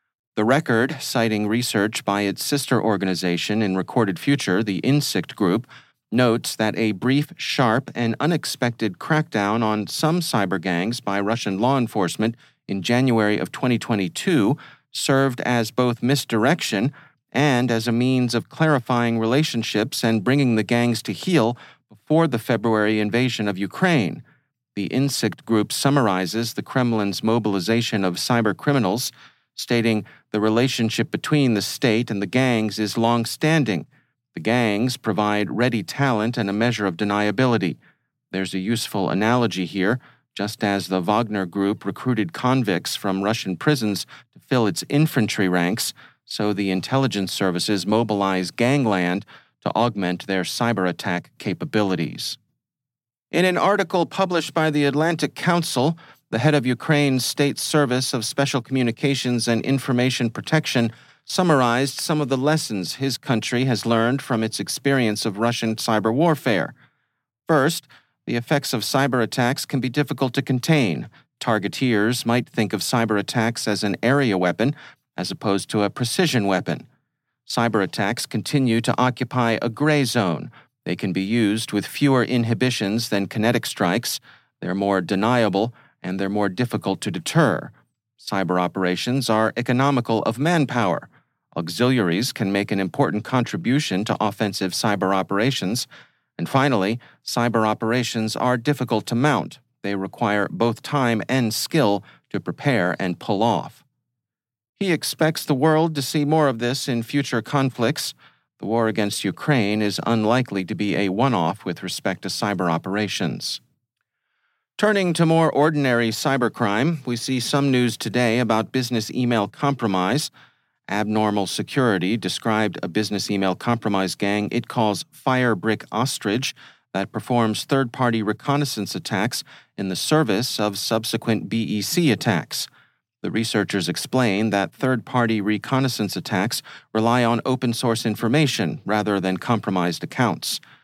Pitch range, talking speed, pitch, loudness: 105-130 Hz, 140 wpm, 115 Hz, -22 LUFS